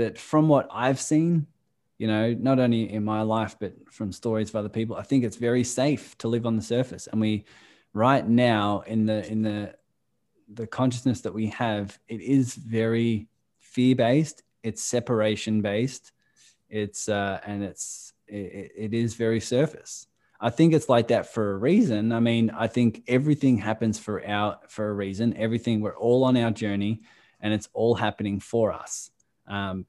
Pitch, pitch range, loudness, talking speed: 115 Hz, 105-120 Hz, -25 LUFS, 180 wpm